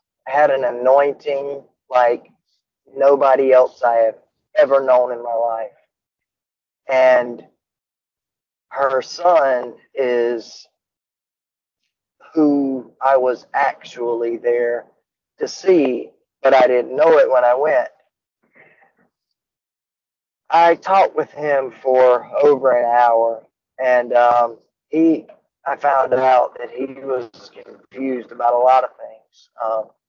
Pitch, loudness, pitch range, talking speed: 130 Hz, -17 LUFS, 120-140 Hz, 110 wpm